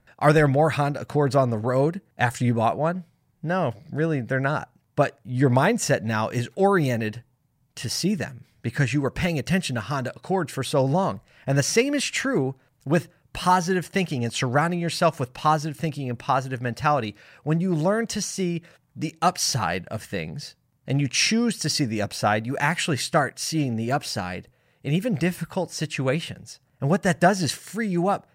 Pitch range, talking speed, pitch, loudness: 130-170 Hz, 185 wpm, 145 Hz, -24 LUFS